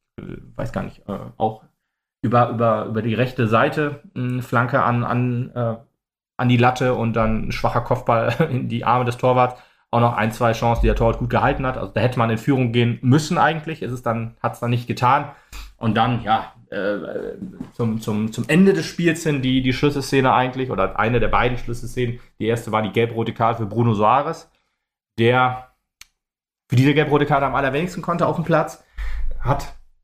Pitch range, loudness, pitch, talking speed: 115-130 Hz, -20 LUFS, 120 Hz, 195 wpm